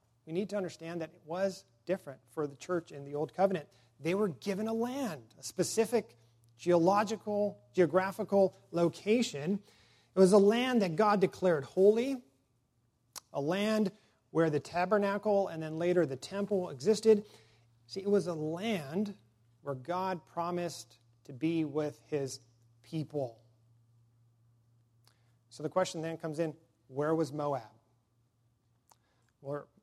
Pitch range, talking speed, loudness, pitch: 120-195 Hz, 135 wpm, -32 LUFS, 160 Hz